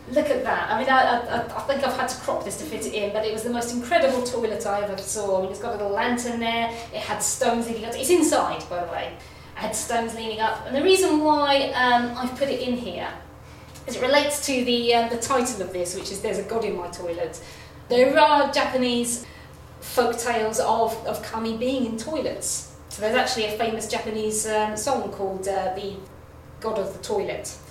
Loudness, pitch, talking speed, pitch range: -24 LUFS, 235 Hz, 225 wpm, 215-255 Hz